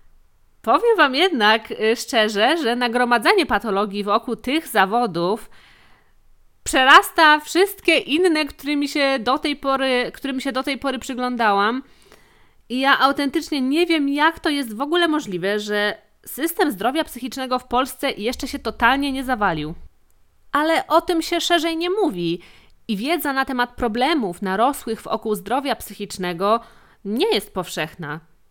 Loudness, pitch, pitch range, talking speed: -20 LUFS, 260 Hz, 220-305 Hz, 135 wpm